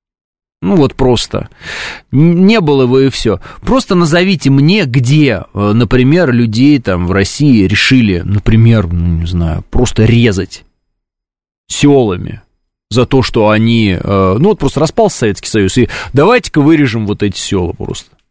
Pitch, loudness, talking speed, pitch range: 115 Hz, -10 LUFS, 140 wpm, 100-140 Hz